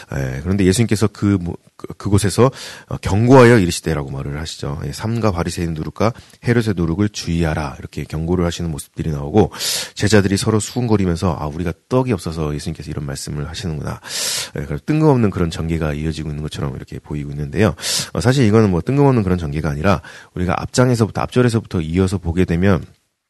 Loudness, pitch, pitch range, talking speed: -18 LUFS, 90 Hz, 80-110 Hz, 445 characters per minute